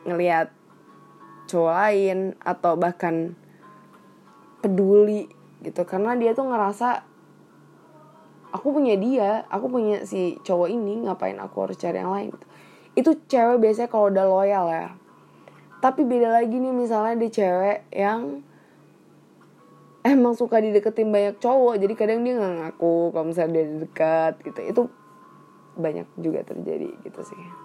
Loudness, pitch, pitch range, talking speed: -23 LUFS, 205 Hz, 175-230 Hz, 130 wpm